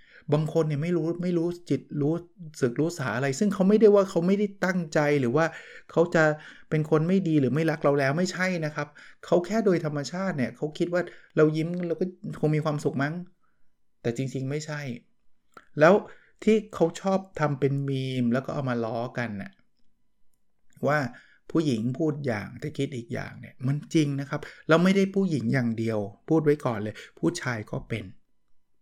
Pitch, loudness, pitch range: 150 Hz, -26 LUFS, 135-170 Hz